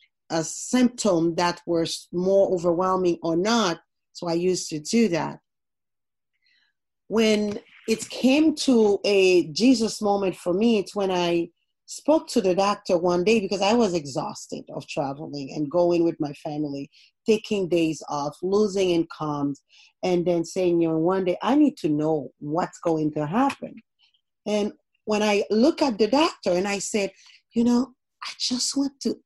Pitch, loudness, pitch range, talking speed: 190 Hz, -23 LUFS, 170-225 Hz, 160 wpm